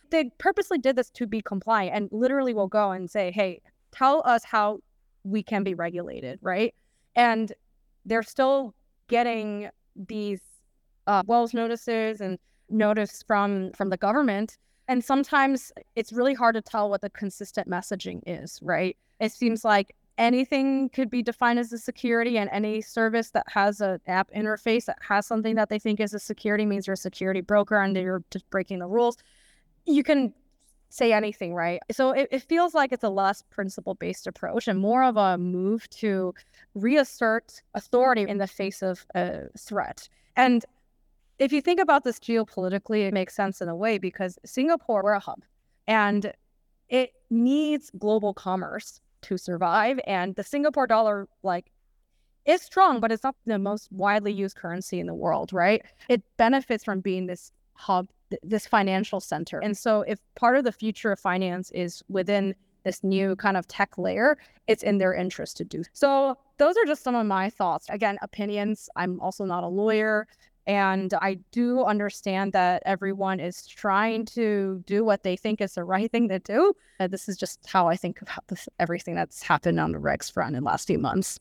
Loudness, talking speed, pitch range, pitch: -26 LUFS, 185 wpm, 195-235 Hz, 210 Hz